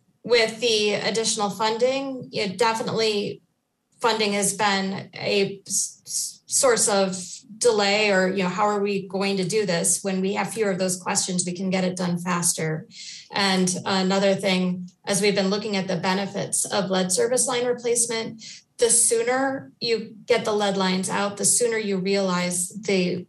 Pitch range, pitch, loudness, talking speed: 190-220 Hz, 200 Hz, -22 LUFS, 165 wpm